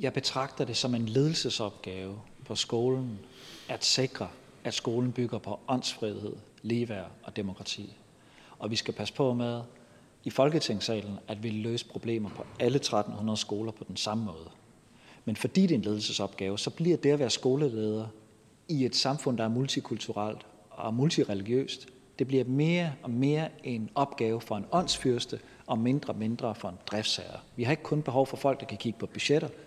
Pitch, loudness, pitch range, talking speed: 120 Hz, -31 LUFS, 110-135 Hz, 175 wpm